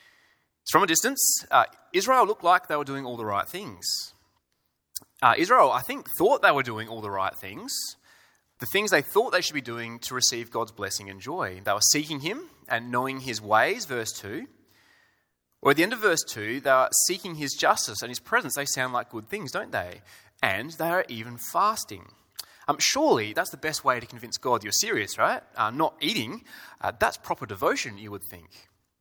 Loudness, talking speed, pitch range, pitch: -25 LUFS, 205 wpm, 110-155 Hz, 125 Hz